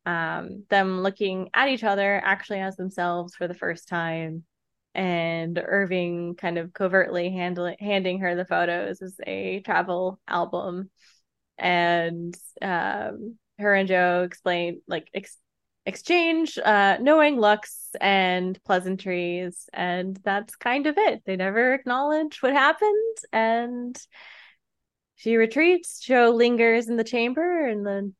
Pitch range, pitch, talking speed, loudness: 175-230 Hz, 195 Hz, 130 wpm, -24 LUFS